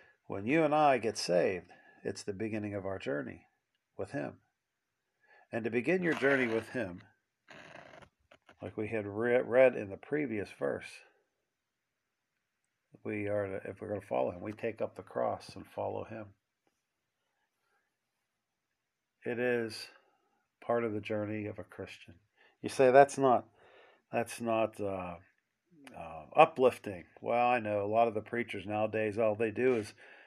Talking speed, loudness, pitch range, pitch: 150 wpm, -32 LUFS, 105-125 Hz, 115 Hz